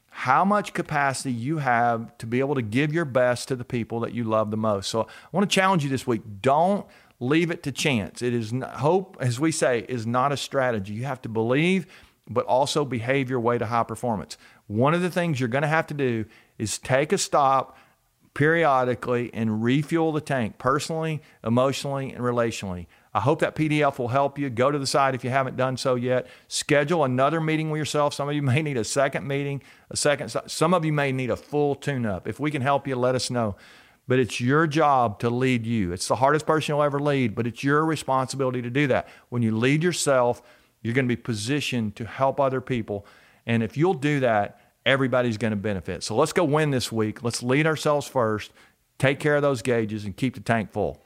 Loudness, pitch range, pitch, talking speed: -24 LUFS, 120-145 Hz, 130 Hz, 225 wpm